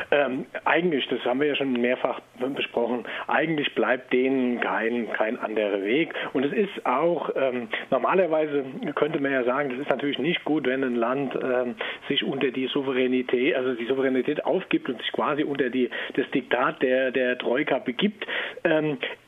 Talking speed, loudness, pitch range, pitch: 170 wpm, -25 LUFS, 125-140 Hz, 130 Hz